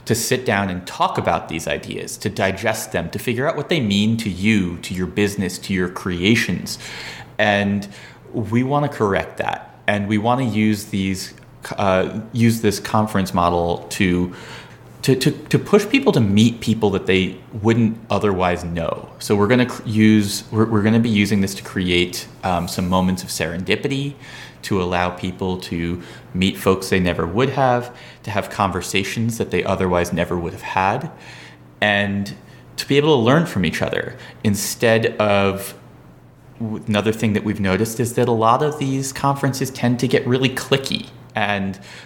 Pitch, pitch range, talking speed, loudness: 105 Hz, 95-120 Hz, 175 wpm, -19 LUFS